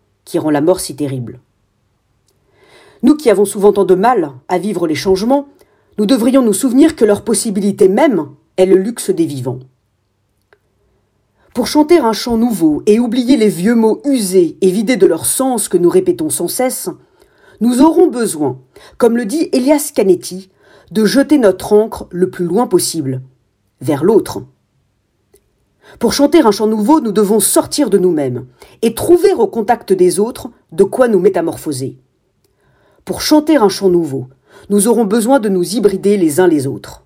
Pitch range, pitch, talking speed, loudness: 150-245 Hz, 200 Hz, 170 wpm, -13 LUFS